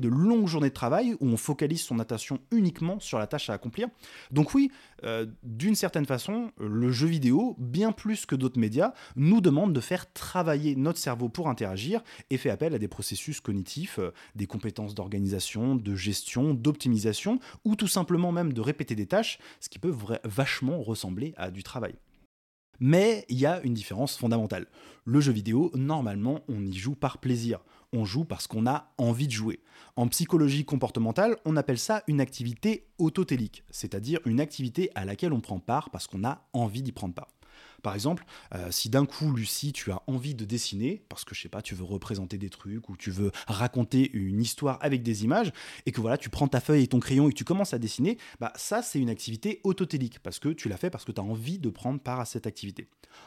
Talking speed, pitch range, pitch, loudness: 210 wpm, 110-150 Hz, 125 Hz, -29 LUFS